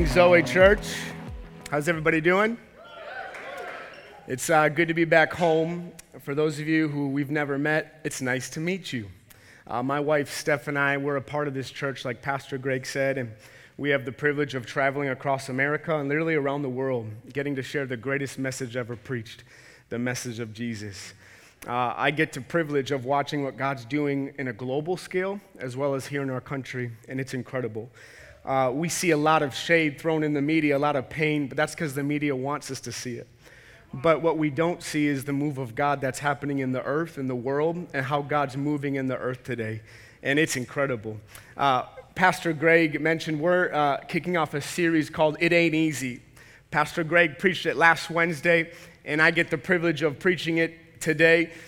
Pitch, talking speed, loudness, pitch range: 145 Hz, 200 wpm, -25 LUFS, 130-160 Hz